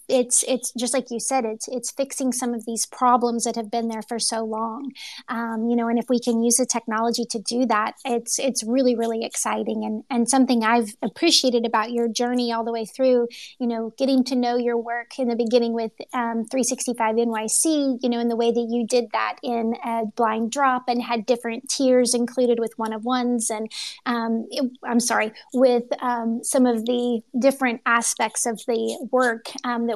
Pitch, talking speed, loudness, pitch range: 235 Hz, 205 wpm, -22 LUFS, 230-250 Hz